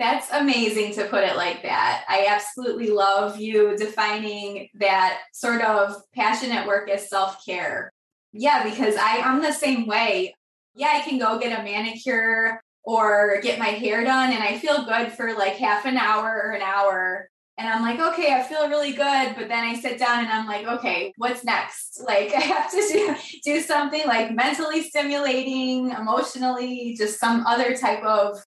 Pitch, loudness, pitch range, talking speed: 225 Hz, -22 LUFS, 210-260 Hz, 180 wpm